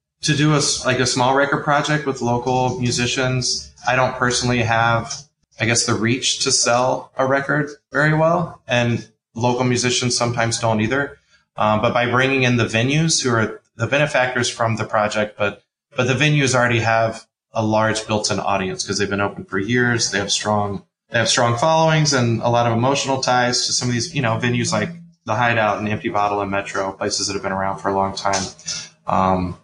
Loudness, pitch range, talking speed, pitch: -19 LUFS, 110-130 Hz, 200 wpm, 120 Hz